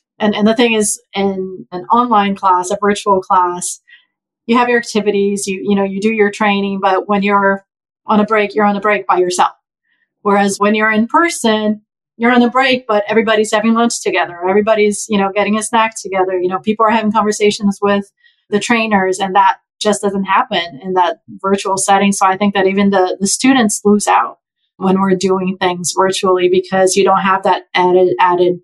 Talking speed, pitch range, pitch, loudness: 200 wpm, 190-215 Hz, 200 Hz, -13 LUFS